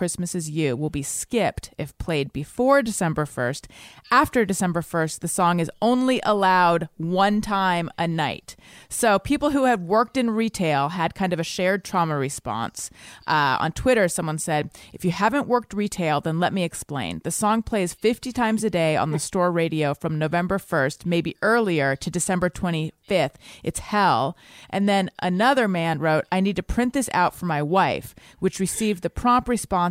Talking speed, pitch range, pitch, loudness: 185 wpm, 155-210 Hz, 180 Hz, -23 LUFS